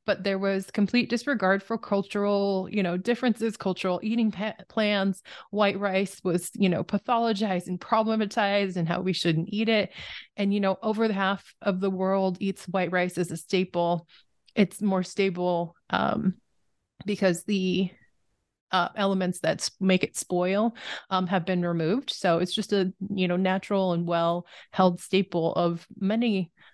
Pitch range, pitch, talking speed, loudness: 180-205 Hz, 195 Hz, 160 wpm, -27 LUFS